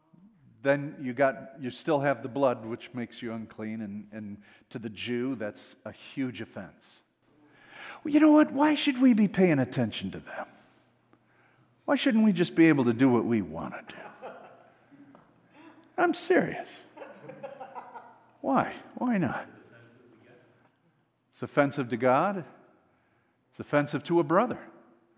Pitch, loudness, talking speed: 140 Hz, -27 LUFS, 145 wpm